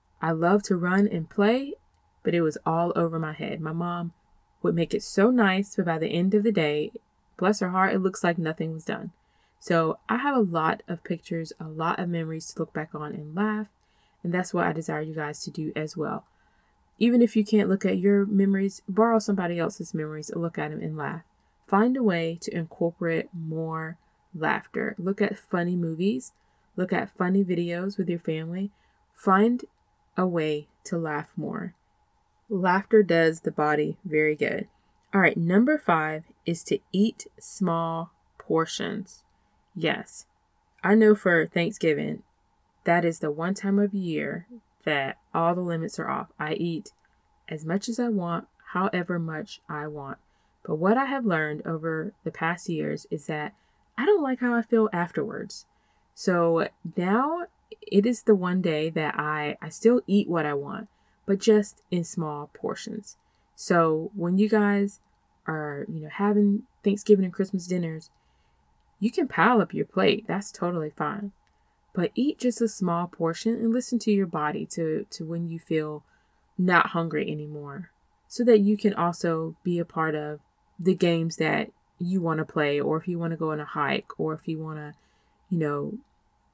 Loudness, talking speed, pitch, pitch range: -26 LUFS, 180 wpm, 175 Hz, 160-210 Hz